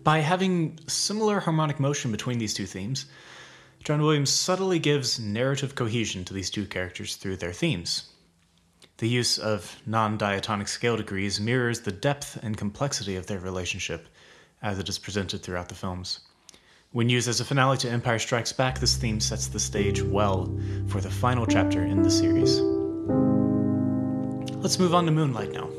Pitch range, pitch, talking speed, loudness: 95-130 Hz, 105 Hz, 170 wpm, -26 LUFS